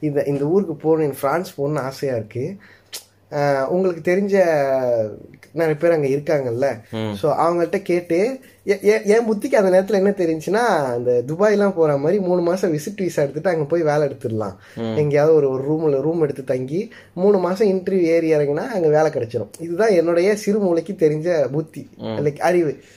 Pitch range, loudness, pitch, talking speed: 140-185 Hz, -19 LUFS, 160 Hz, 155 wpm